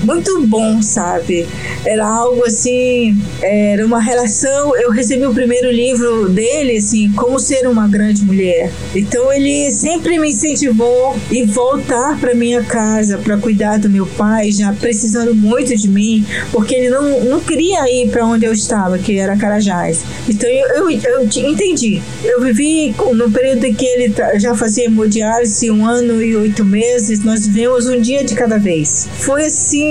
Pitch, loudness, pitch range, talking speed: 235 Hz, -13 LUFS, 215-255 Hz, 165 wpm